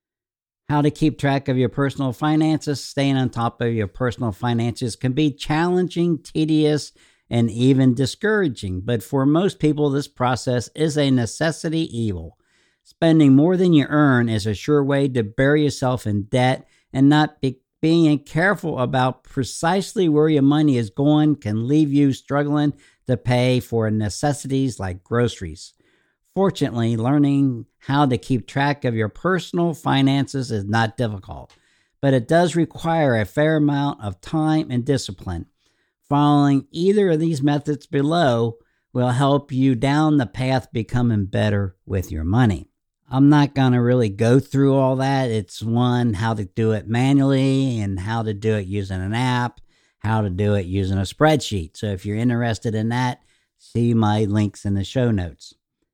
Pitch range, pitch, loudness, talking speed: 115-145 Hz, 130 Hz, -20 LUFS, 165 wpm